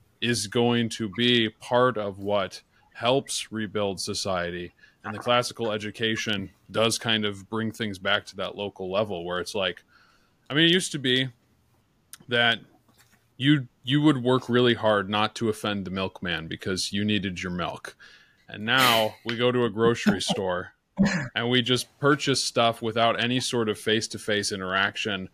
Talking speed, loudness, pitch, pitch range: 170 wpm, -25 LUFS, 110 Hz, 105-120 Hz